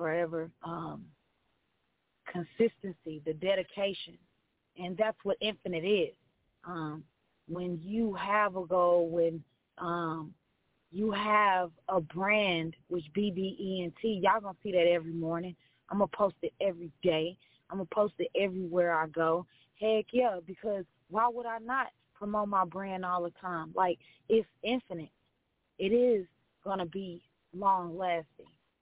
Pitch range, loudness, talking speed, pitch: 165-205 Hz, -32 LUFS, 140 wpm, 180 Hz